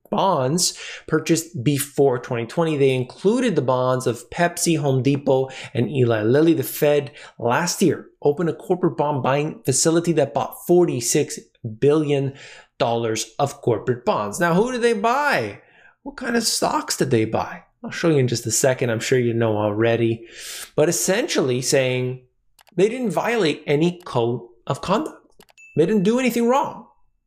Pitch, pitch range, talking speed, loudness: 145 Hz, 125-175 Hz, 155 wpm, -21 LUFS